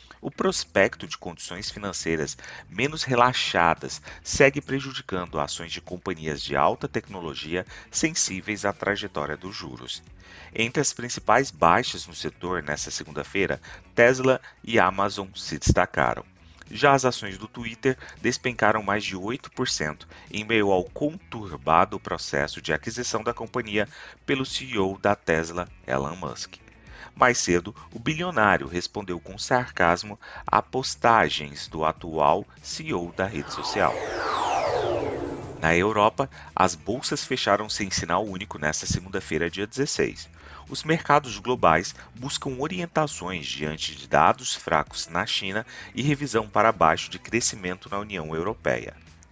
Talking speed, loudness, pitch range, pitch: 125 wpm, -25 LUFS, 85-115 Hz, 95 Hz